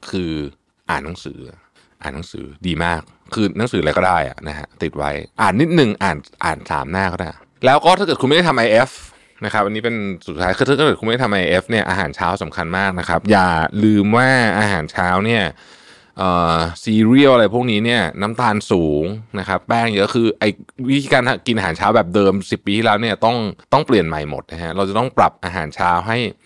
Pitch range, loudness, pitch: 90-115 Hz, -17 LUFS, 100 Hz